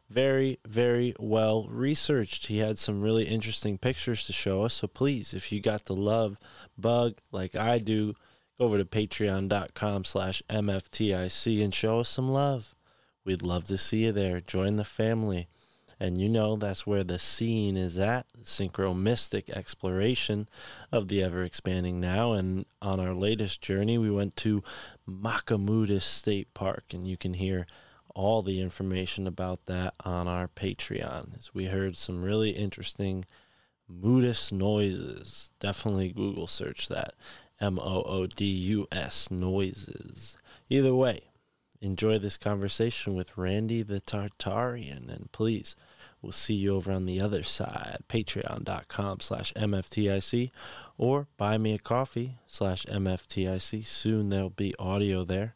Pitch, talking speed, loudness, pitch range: 100 Hz, 140 wpm, -30 LUFS, 95-110 Hz